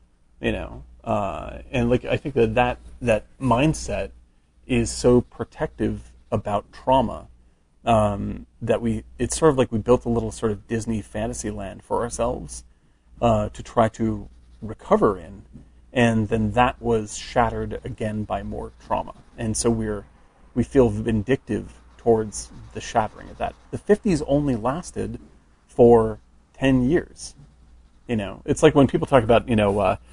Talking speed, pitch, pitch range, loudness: 155 wpm, 110 Hz, 100-125 Hz, -23 LUFS